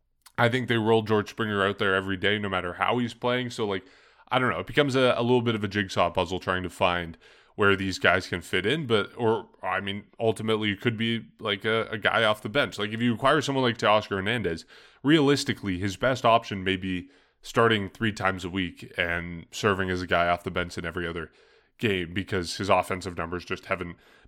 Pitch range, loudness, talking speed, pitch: 90-115 Hz, -26 LUFS, 225 wpm, 100 Hz